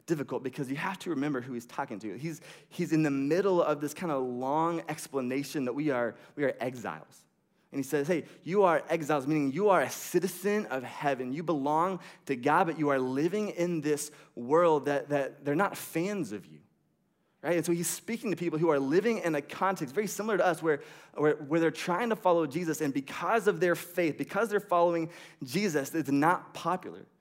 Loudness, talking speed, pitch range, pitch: -30 LUFS, 210 wpm, 145-180 Hz, 165 Hz